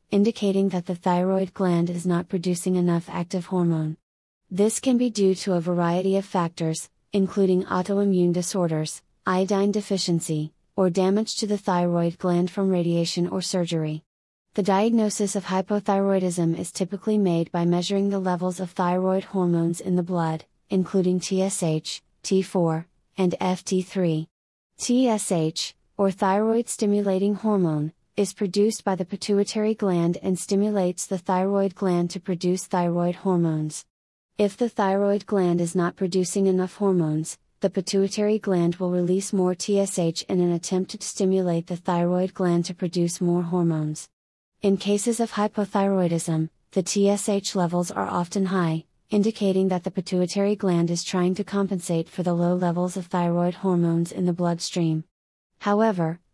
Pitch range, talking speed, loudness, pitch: 175-195 Hz, 145 wpm, -24 LUFS, 185 Hz